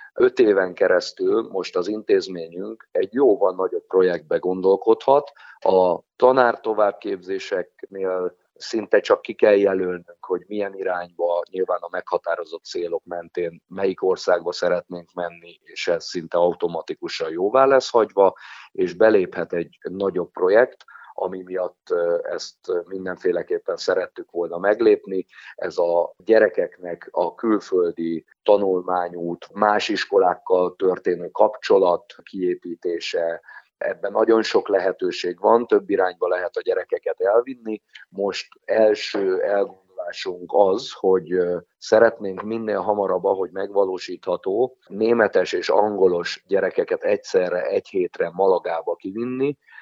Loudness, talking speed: -22 LUFS, 110 wpm